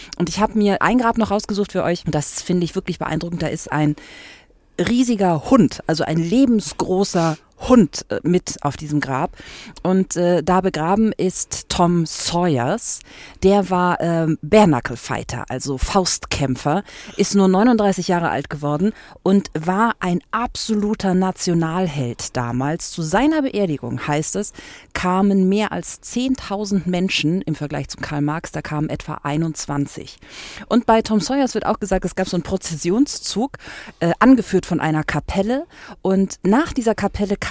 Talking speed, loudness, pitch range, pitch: 150 wpm, -19 LUFS, 155-205 Hz, 180 Hz